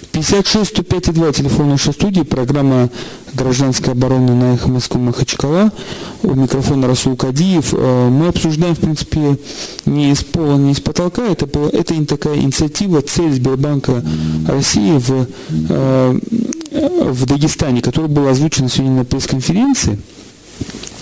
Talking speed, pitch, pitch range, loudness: 125 wpm, 145 Hz, 130-165 Hz, -14 LUFS